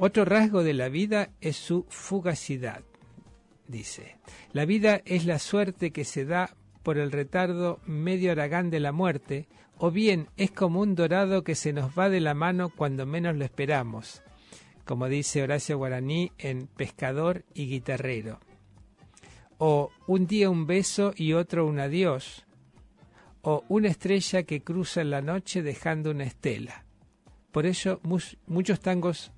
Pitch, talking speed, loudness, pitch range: 160 Hz, 155 wpm, -28 LUFS, 140-185 Hz